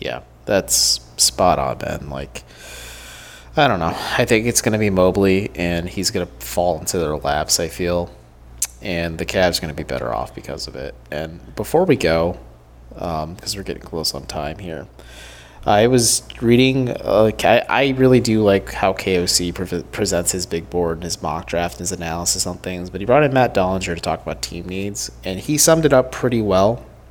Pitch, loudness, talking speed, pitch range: 90 Hz, -18 LUFS, 200 wpm, 80-100 Hz